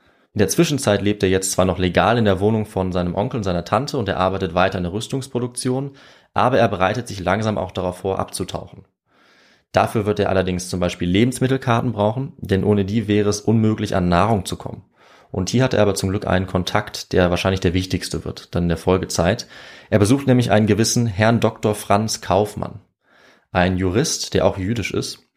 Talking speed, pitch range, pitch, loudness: 200 wpm, 95-110 Hz, 100 Hz, -19 LUFS